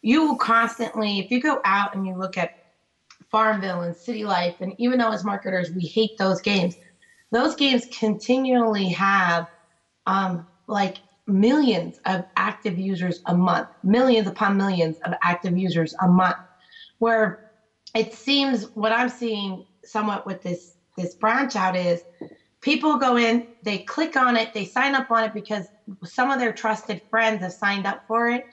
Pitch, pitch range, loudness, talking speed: 210 Hz, 185-230 Hz, -23 LUFS, 170 wpm